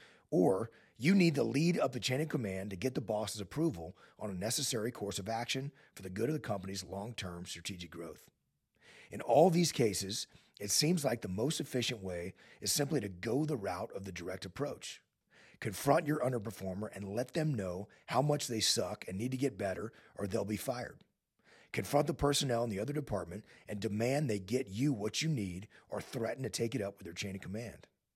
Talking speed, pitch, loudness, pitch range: 210 wpm, 115 Hz, -35 LUFS, 100-145 Hz